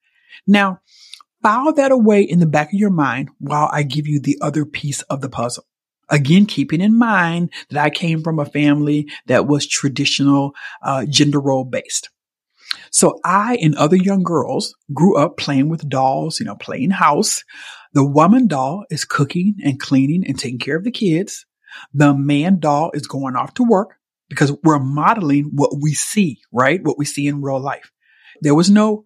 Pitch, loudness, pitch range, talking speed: 150 Hz, -16 LUFS, 145-195 Hz, 185 wpm